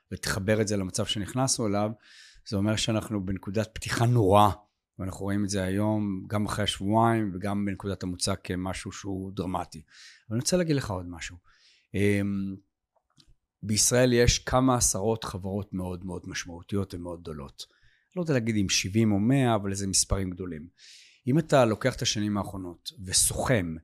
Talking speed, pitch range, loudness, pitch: 155 wpm, 95-110 Hz, -27 LUFS, 100 Hz